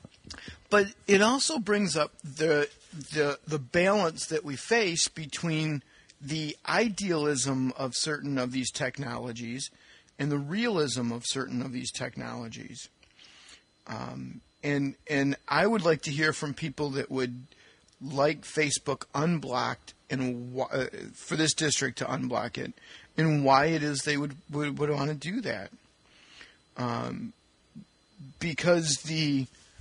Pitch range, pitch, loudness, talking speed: 130-160 Hz, 145 Hz, -29 LUFS, 135 wpm